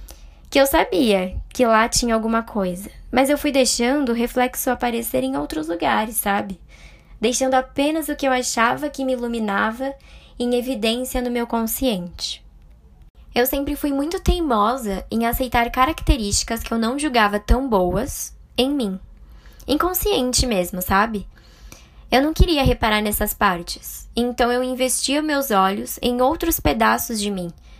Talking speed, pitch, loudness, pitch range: 145 wpm, 240 Hz, -20 LUFS, 205-265 Hz